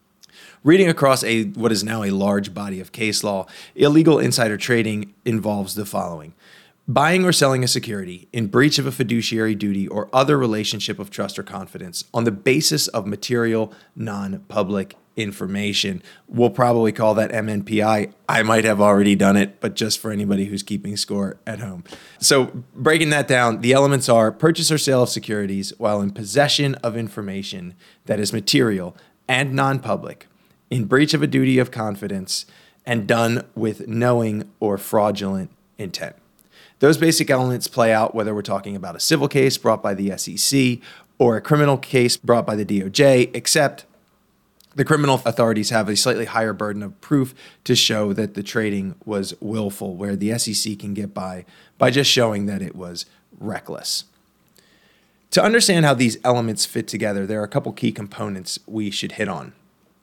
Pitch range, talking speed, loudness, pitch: 100-125 Hz, 170 wpm, -19 LUFS, 110 Hz